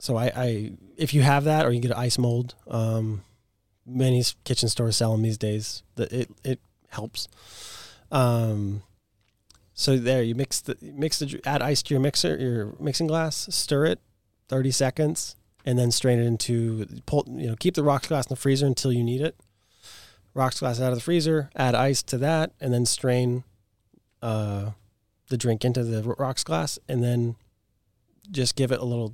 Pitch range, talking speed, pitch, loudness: 105-130 Hz, 185 wpm, 120 Hz, -25 LUFS